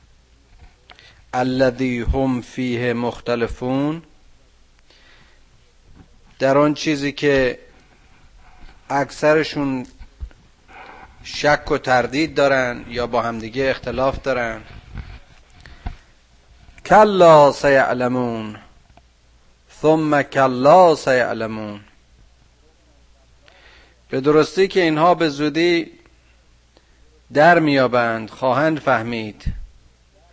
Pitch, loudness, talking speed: 120 Hz, -17 LUFS, 65 wpm